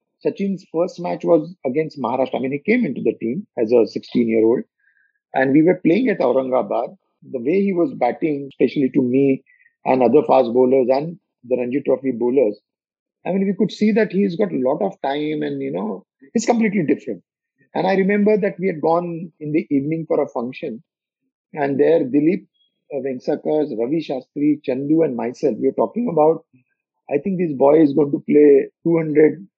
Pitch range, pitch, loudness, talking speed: 140-195 Hz, 160 Hz, -19 LUFS, 190 wpm